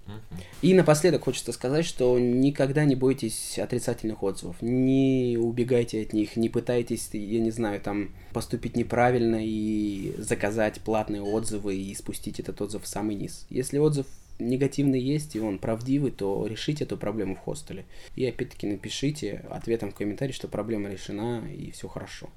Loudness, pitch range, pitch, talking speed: -27 LUFS, 105-125 Hz, 115 Hz, 155 wpm